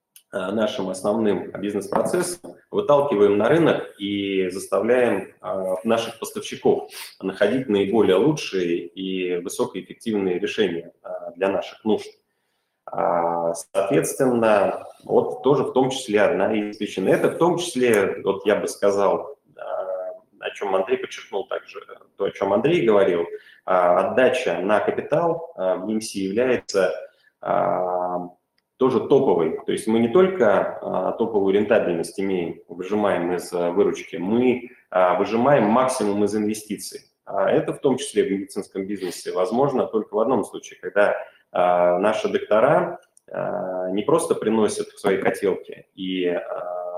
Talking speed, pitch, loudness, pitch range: 135 wpm, 105 Hz, -22 LUFS, 95-145 Hz